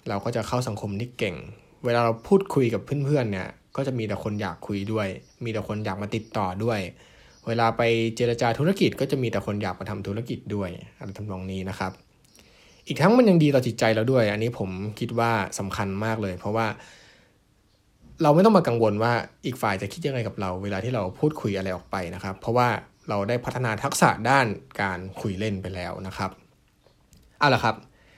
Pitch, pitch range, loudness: 110 Hz, 100-125 Hz, -25 LUFS